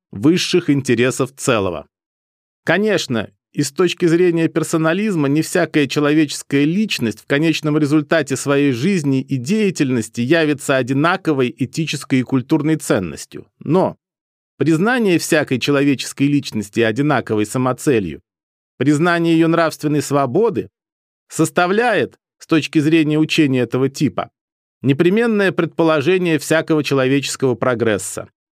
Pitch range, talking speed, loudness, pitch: 130-165 Hz, 105 wpm, -17 LUFS, 150 Hz